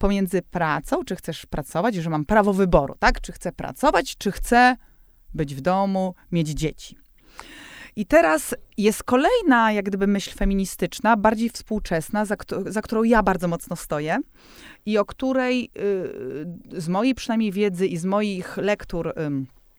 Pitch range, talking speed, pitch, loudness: 175-220 Hz, 155 wpm, 200 Hz, -23 LUFS